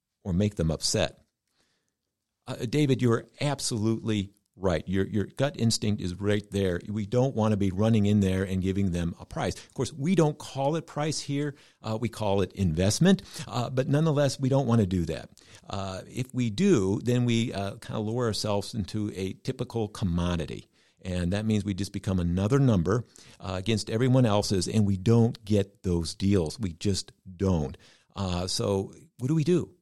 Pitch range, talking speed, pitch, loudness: 95-125 Hz, 190 wpm, 105 Hz, -28 LUFS